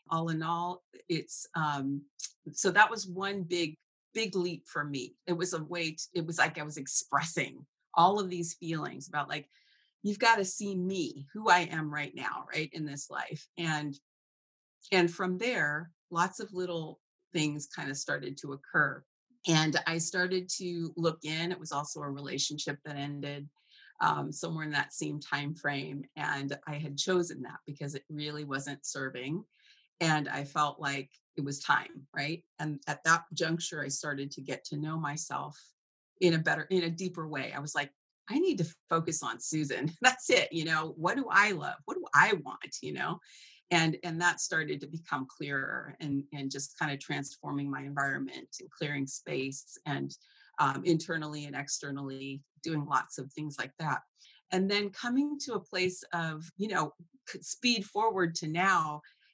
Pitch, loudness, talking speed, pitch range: 160 Hz, -32 LUFS, 180 wpm, 145-175 Hz